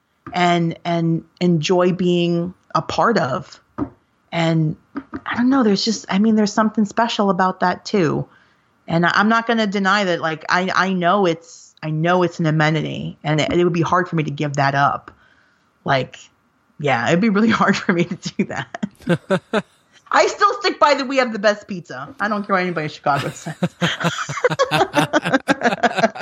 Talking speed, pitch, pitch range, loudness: 180 wpm, 180 Hz, 165-220 Hz, -19 LUFS